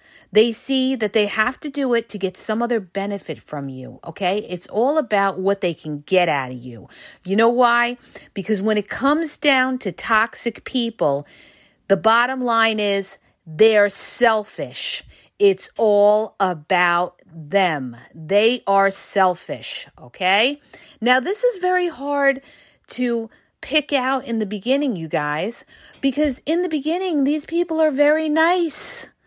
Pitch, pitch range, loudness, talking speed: 220 Hz, 190-275 Hz, -20 LUFS, 150 wpm